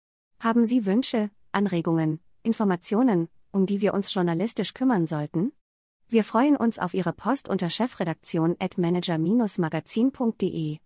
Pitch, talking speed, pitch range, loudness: 195 Hz, 120 wpm, 170-230 Hz, -25 LUFS